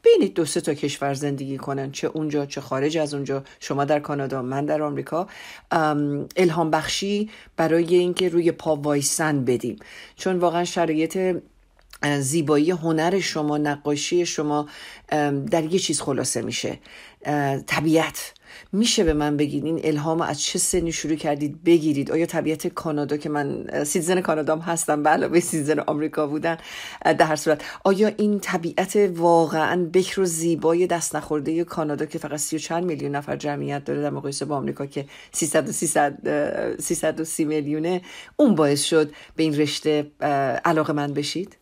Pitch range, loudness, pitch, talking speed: 145-170 Hz, -23 LUFS, 155 Hz, 155 wpm